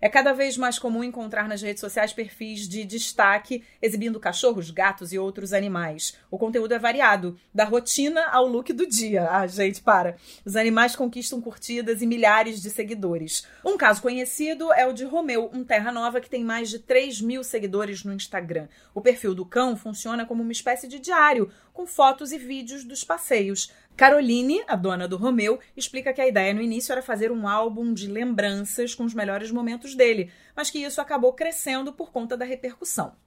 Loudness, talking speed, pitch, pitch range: -24 LUFS, 190 wpm, 235 Hz, 210-260 Hz